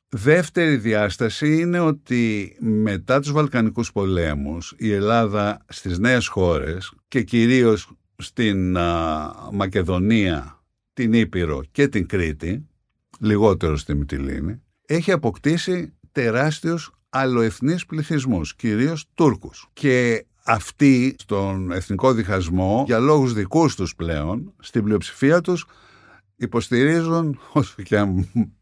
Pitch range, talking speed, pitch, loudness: 95-135 Hz, 100 wpm, 115 Hz, -21 LUFS